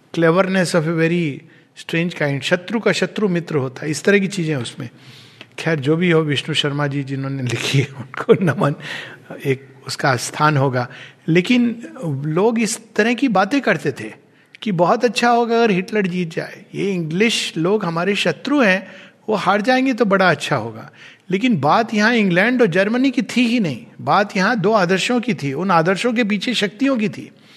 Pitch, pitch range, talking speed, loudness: 180 Hz, 150-215 Hz, 185 wpm, -18 LUFS